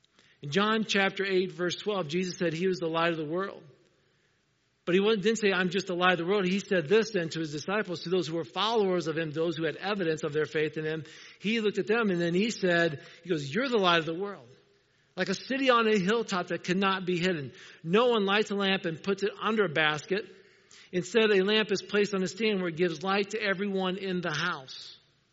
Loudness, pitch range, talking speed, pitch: -28 LUFS, 170-200 Hz, 240 wpm, 185 Hz